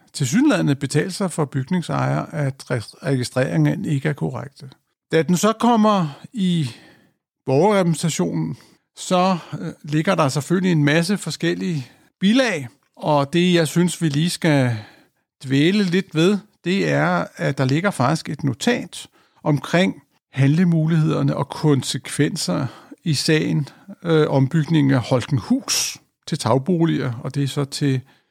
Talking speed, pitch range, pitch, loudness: 125 wpm, 140-180 Hz, 155 Hz, -20 LUFS